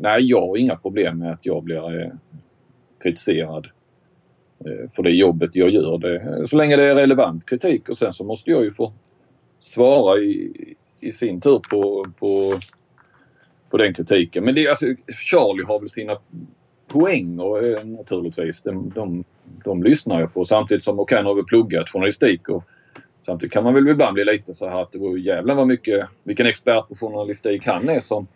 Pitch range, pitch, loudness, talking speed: 90-125 Hz, 105 Hz, -19 LUFS, 180 wpm